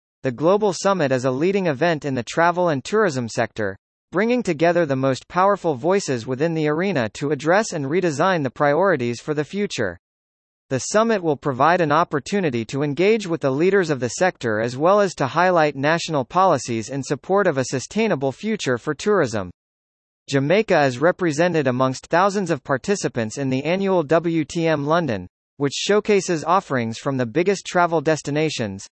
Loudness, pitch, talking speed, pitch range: -20 LUFS, 155 Hz, 165 wpm, 130-180 Hz